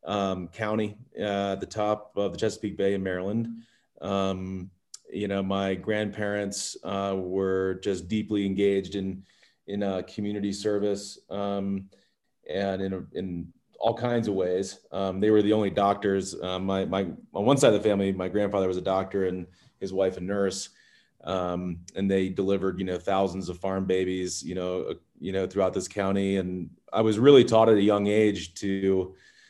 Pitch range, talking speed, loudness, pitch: 95-105 Hz, 180 wpm, -27 LUFS, 95 Hz